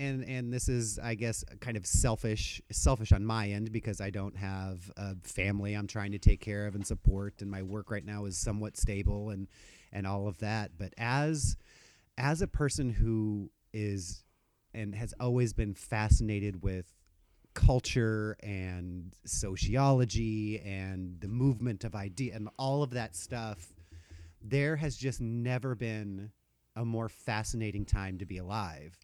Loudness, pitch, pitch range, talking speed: -34 LUFS, 105 Hz, 95-115 Hz, 160 wpm